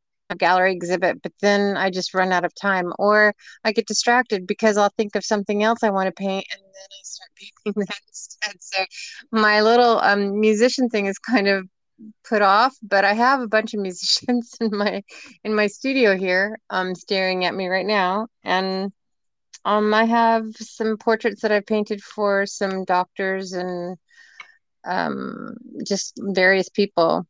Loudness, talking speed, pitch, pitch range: -20 LUFS, 175 wpm, 205 Hz, 190-220 Hz